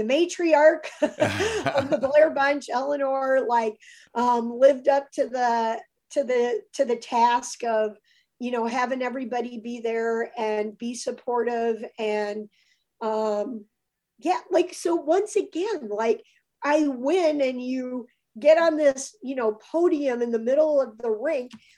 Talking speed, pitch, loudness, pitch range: 145 wpm, 255 Hz, -24 LUFS, 230-300 Hz